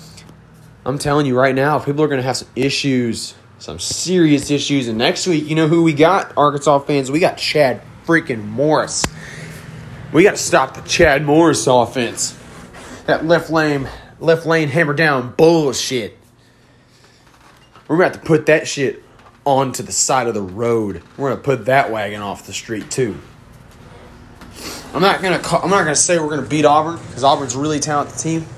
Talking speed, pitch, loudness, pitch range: 180 wpm, 140 Hz, -16 LUFS, 125-155 Hz